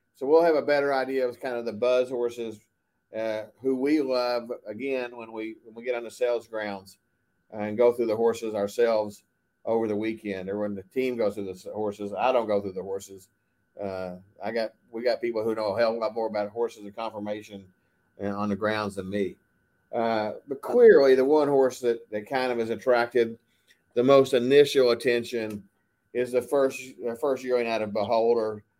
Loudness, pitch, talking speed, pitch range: -26 LUFS, 115 Hz, 205 wpm, 105-125 Hz